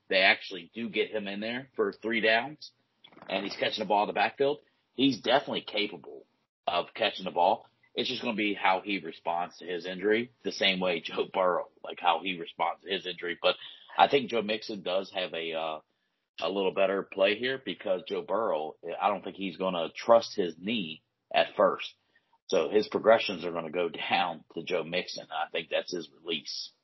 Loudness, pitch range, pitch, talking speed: -30 LUFS, 95-125 Hz, 105 Hz, 205 wpm